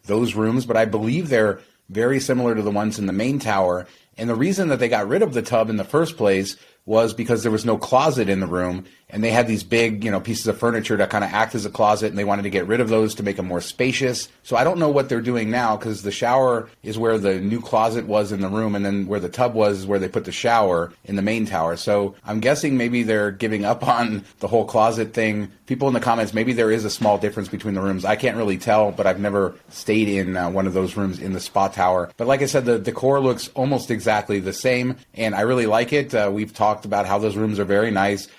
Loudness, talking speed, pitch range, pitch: -21 LUFS, 270 wpm, 100-120 Hz, 110 Hz